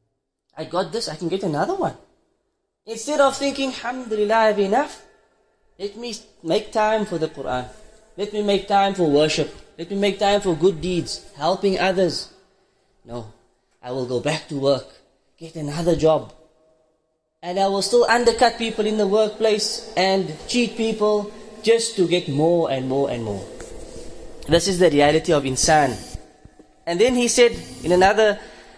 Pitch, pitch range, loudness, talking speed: 190 Hz, 155-220 Hz, -20 LUFS, 165 wpm